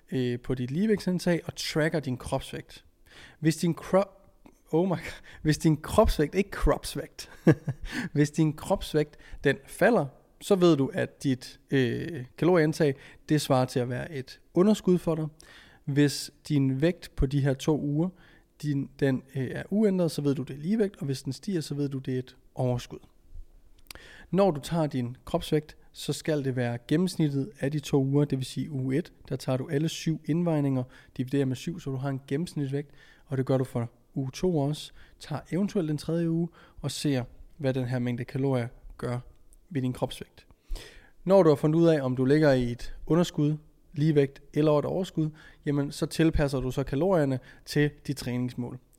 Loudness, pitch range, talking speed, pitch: -28 LUFS, 130-160 Hz, 185 wpm, 145 Hz